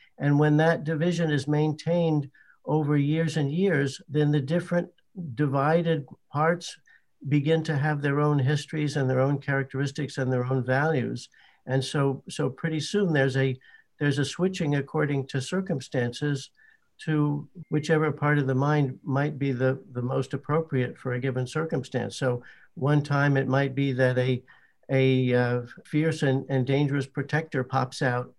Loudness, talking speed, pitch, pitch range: -26 LUFS, 160 wpm, 145 Hz, 135-155 Hz